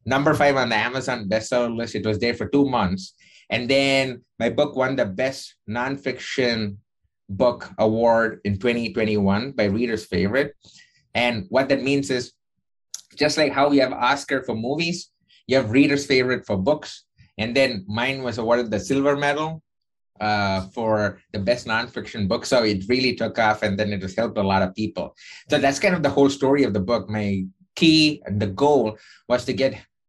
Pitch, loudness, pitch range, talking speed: 125 Hz, -22 LUFS, 110-140 Hz, 190 wpm